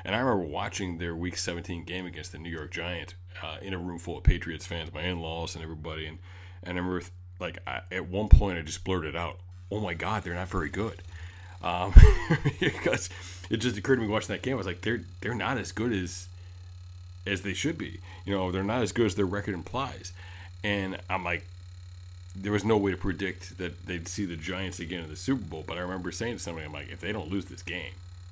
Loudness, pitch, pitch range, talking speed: -30 LUFS, 90 Hz, 90-95 Hz, 240 wpm